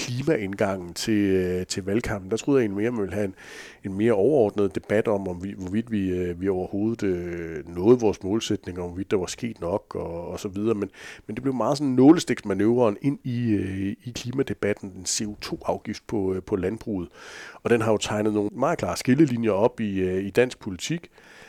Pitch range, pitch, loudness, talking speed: 95-120 Hz, 105 Hz, -25 LUFS, 195 wpm